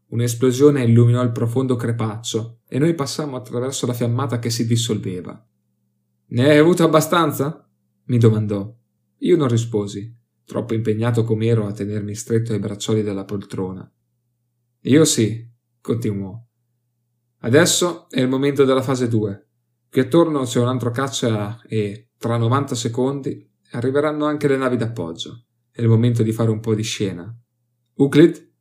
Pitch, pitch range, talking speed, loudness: 120 Hz, 110-130 Hz, 145 wpm, -19 LUFS